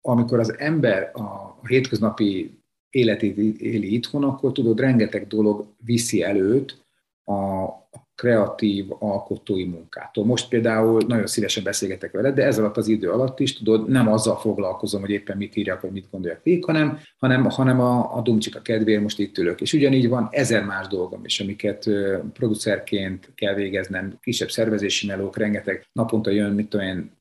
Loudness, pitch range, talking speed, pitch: -22 LUFS, 100-120 Hz, 160 wpm, 110 Hz